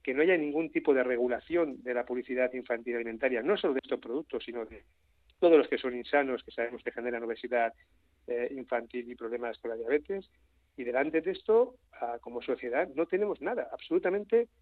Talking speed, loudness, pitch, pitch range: 185 wpm, -31 LUFS, 125 Hz, 120-165 Hz